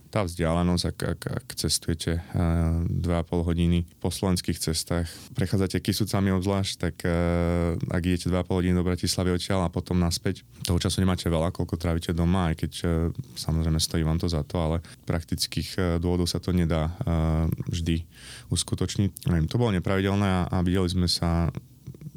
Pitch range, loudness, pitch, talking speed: 85-95 Hz, -26 LUFS, 90 Hz, 160 wpm